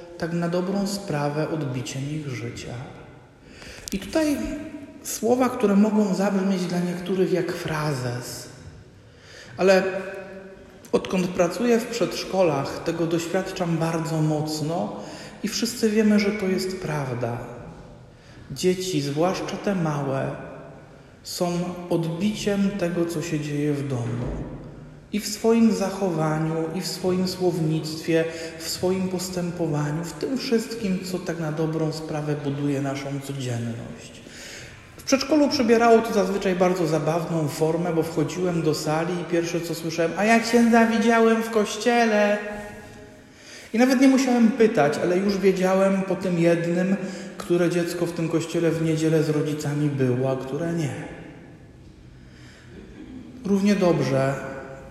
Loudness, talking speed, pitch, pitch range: -23 LUFS, 125 wpm, 170 Hz, 150-195 Hz